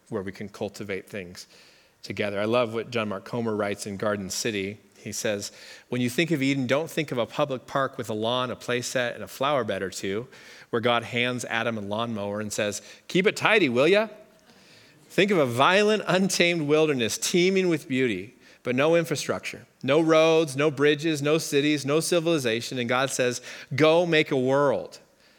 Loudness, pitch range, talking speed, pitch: -25 LUFS, 115-160 Hz, 190 wpm, 135 Hz